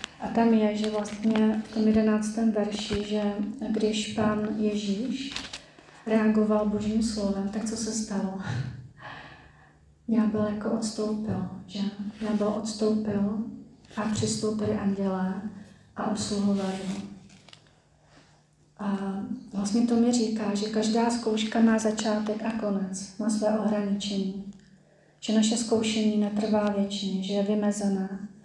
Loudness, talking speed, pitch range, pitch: -27 LUFS, 120 wpm, 200-220 Hz, 210 Hz